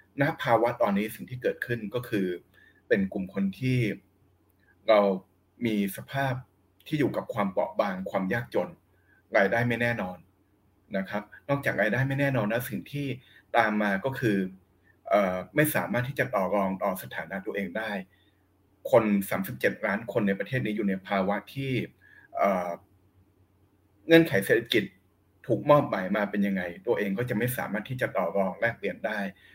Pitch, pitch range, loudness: 100 Hz, 95-120 Hz, -28 LUFS